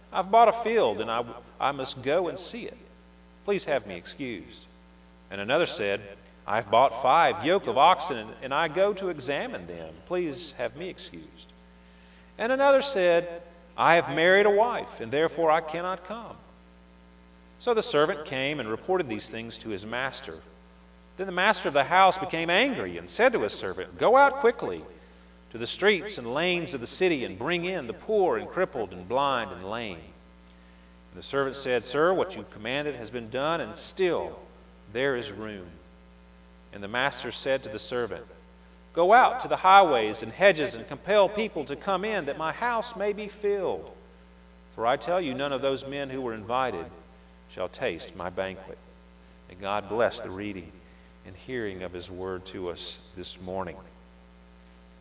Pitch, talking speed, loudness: 110 Hz, 180 wpm, -26 LUFS